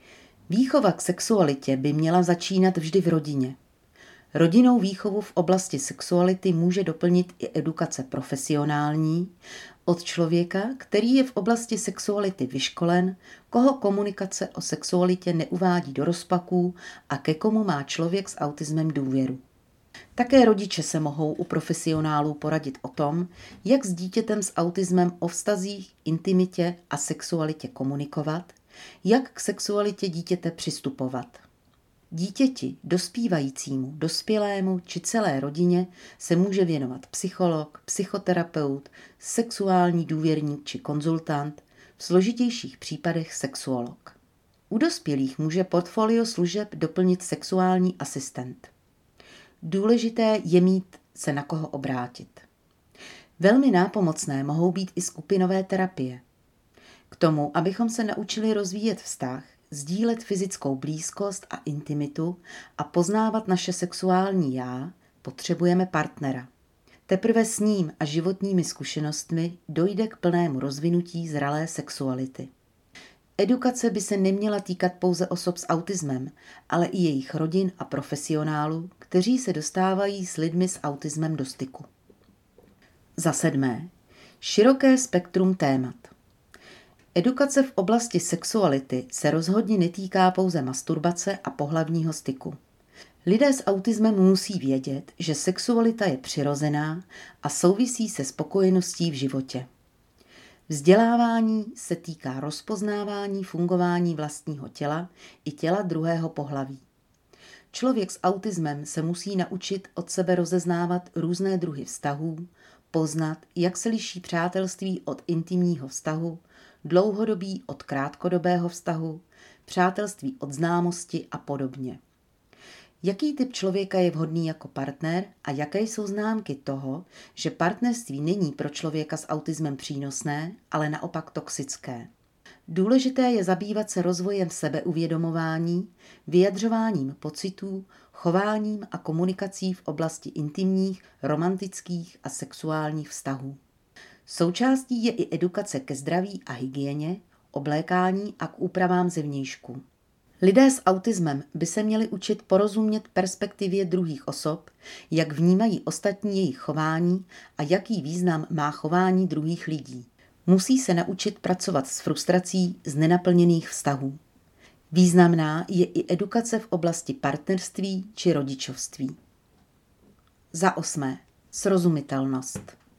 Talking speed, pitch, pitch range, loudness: 115 wpm, 175 Hz, 150-190 Hz, -25 LUFS